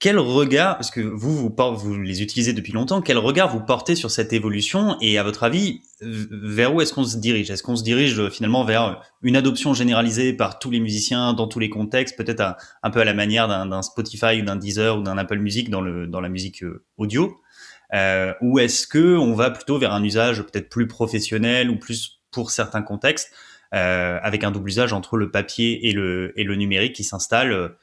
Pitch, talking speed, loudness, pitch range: 115 Hz, 220 wpm, -21 LUFS, 105-125 Hz